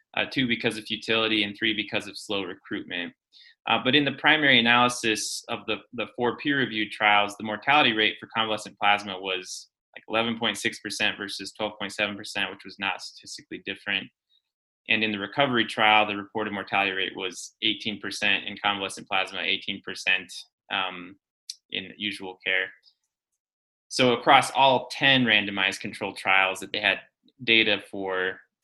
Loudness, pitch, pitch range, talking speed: -24 LUFS, 105 Hz, 100-115 Hz, 150 wpm